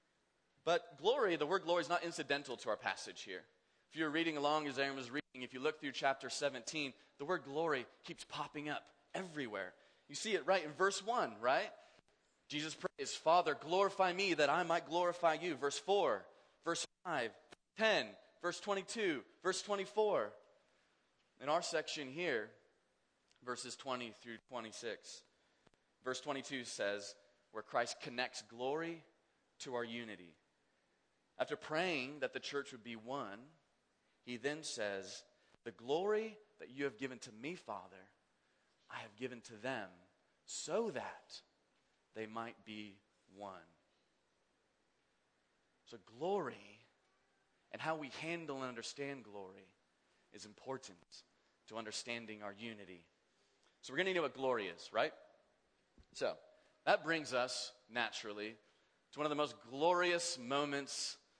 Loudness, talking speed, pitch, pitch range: -40 LUFS, 145 wpm, 140 Hz, 115-170 Hz